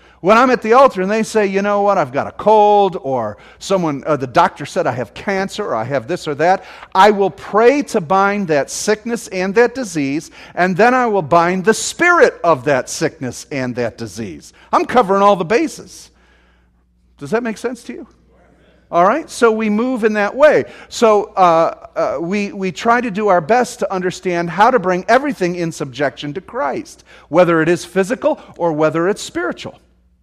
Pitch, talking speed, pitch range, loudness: 195 Hz, 200 wpm, 160-225 Hz, -15 LUFS